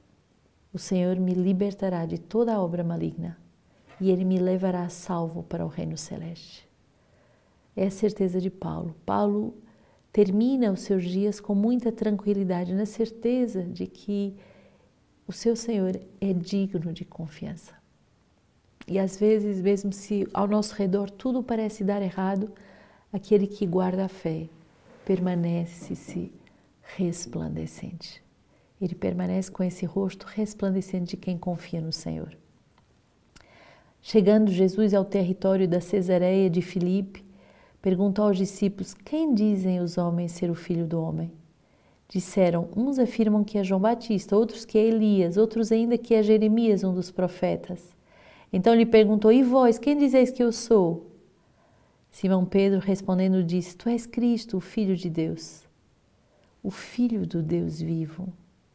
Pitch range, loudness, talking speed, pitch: 180-210 Hz, -25 LUFS, 140 wpm, 190 Hz